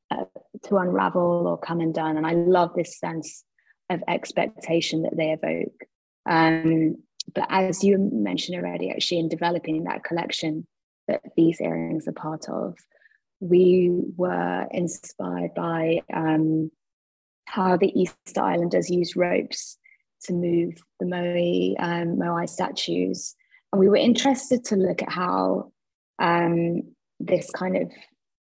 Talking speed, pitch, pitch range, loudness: 135 wpm, 170 Hz, 160-180 Hz, -24 LUFS